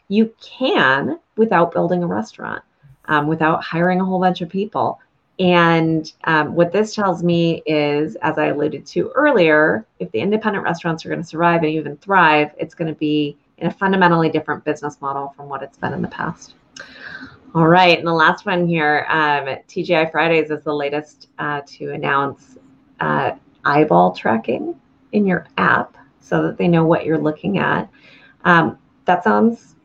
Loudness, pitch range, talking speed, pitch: -18 LUFS, 150-180 Hz, 175 wpm, 160 Hz